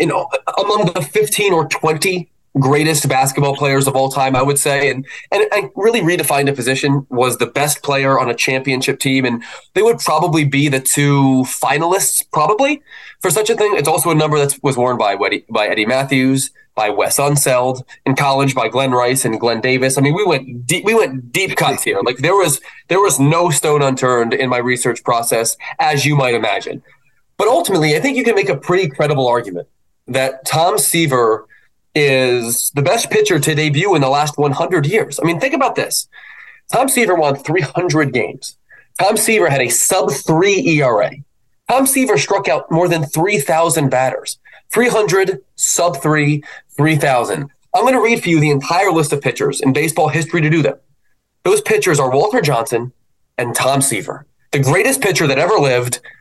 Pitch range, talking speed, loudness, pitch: 130-175 Hz, 190 wpm, -14 LUFS, 145 Hz